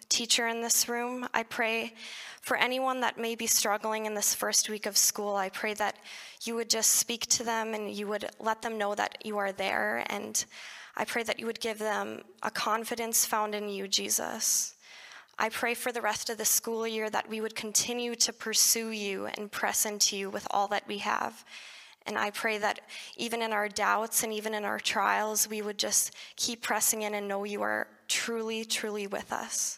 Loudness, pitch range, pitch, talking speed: -29 LUFS, 210-230 Hz, 220 Hz, 210 wpm